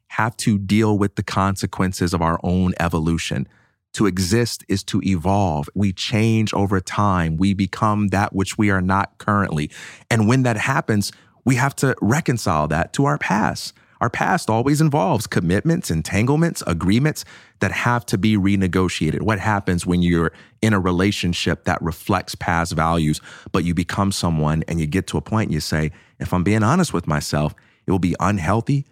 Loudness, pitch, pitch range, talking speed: -20 LUFS, 95 Hz, 85-110 Hz, 175 wpm